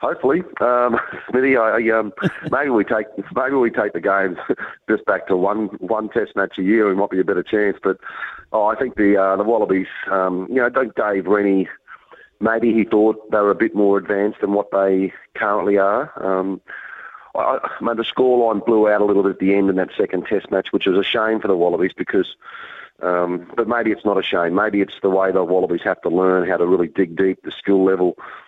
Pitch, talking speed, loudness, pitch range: 100 Hz, 230 wpm, -19 LUFS, 95-110 Hz